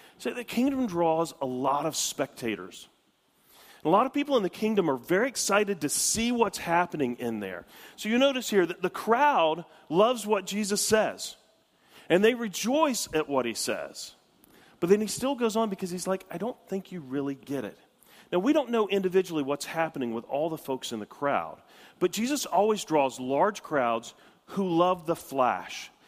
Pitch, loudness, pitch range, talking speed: 180 Hz, -28 LUFS, 140-220 Hz, 190 wpm